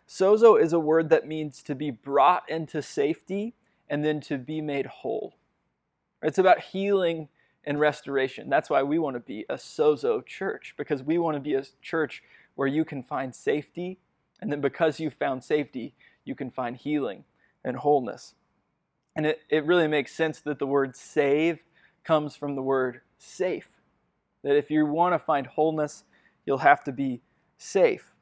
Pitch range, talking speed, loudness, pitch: 140-165 Hz, 175 wpm, -26 LUFS, 150 Hz